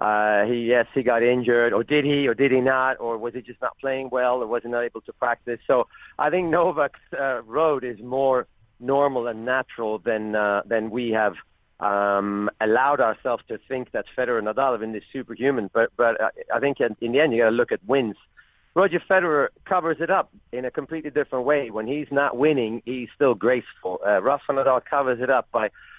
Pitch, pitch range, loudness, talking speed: 125 Hz, 115-140 Hz, -23 LUFS, 215 wpm